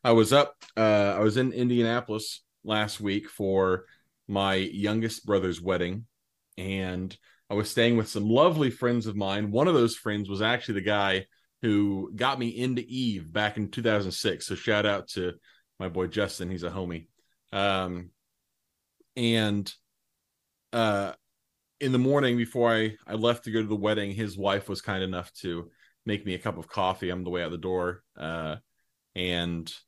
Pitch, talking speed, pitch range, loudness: 105 Hz, 175 wpm, 95-115 Hz, -28 LUFS